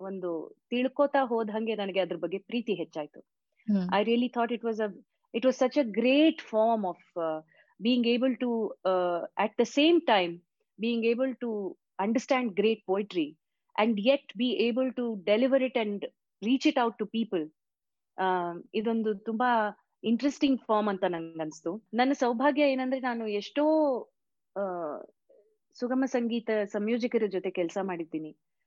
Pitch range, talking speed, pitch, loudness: 190-255 Hz, 130 wpm, 225 Hz, -29 LUFS